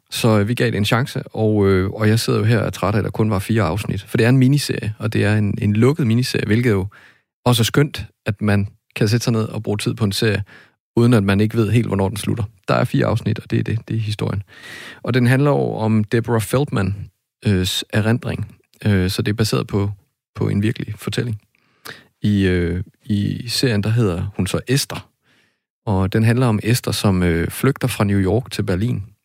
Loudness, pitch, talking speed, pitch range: -19 LUFS, 110 Hz, 220 wpm, 105-120 Hz